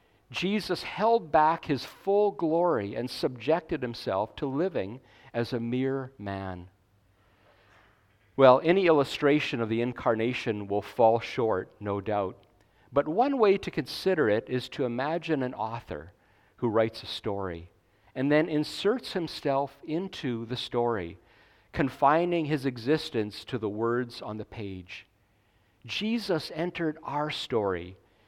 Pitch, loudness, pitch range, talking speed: 120 Hz, -28 LUFS, 105-155 Hz, 130 wpm